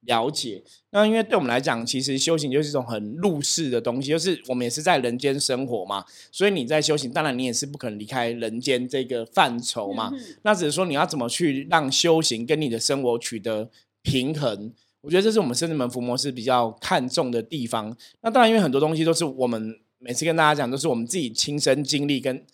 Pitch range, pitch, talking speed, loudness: 120-160 Hz, 135 Hz, 345 characters per minute, -23 LUFS